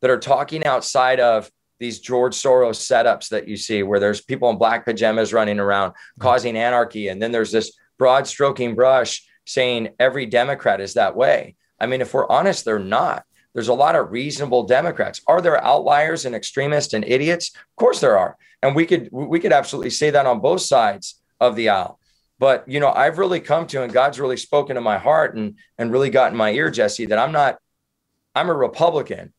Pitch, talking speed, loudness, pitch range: 125 Hz, 205 wpm, -19 LUFS, 110-140 Hz